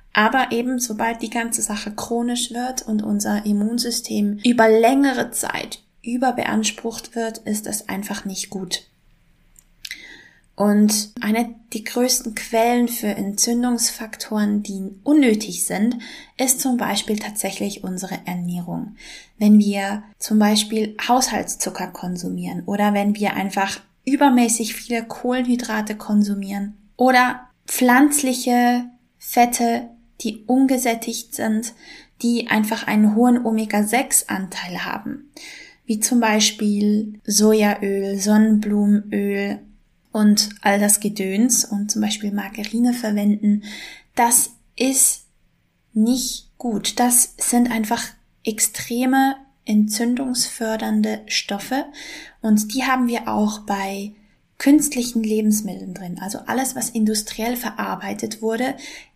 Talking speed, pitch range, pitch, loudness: 105 wpm, 205-245 Hz, 225 Hz, -20 LUFS